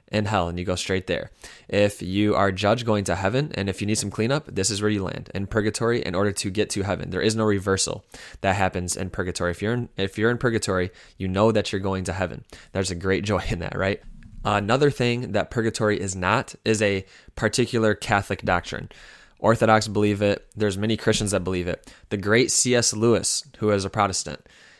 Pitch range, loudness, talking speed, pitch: 95-110 Hz, -23 LUFS, 220 wpm, 105 Hz